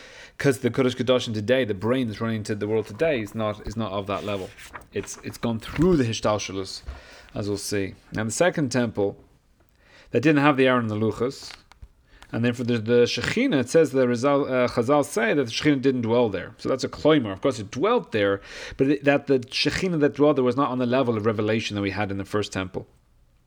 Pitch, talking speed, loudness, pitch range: 120 Hz, 235 wpm, -24 LUFS, 105-135 Hz